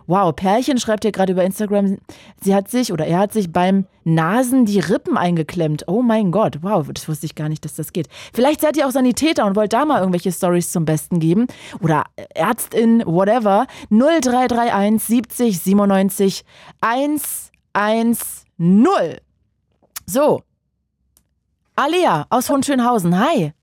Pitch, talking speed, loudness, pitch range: 200 Hz, 145 wpm, -17 LUFS, 175-240 Hz